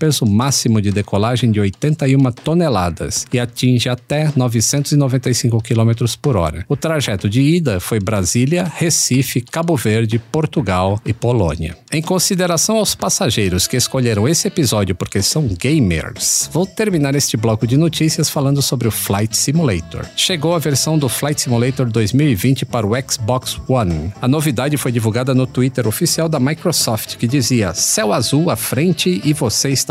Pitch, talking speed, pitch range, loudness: 130 Hz, 155 wpm, 110-150 Hz, -16 LUFS